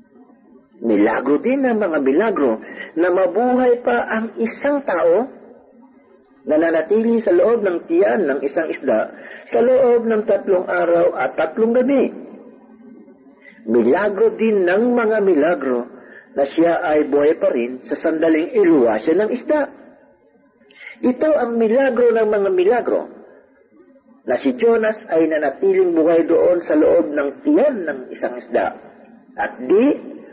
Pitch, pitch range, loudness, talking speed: 225 Hz, 170-255 Hz, -17 LUFS, 130 wpm